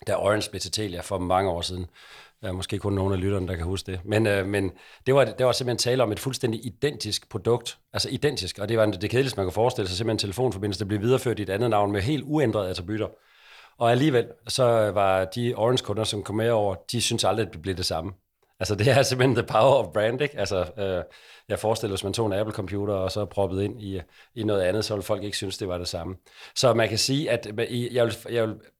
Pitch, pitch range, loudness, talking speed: 105 Hz, 95-120 Hz, -25 LUFS, 250 wpm